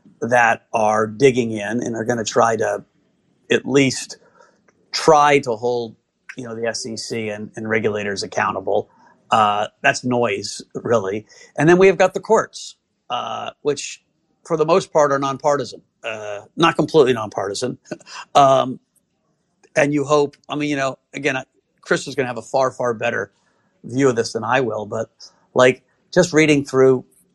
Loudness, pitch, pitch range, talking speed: -19 LUFS, 130 Hz, 115-145 Hz, 165 wpm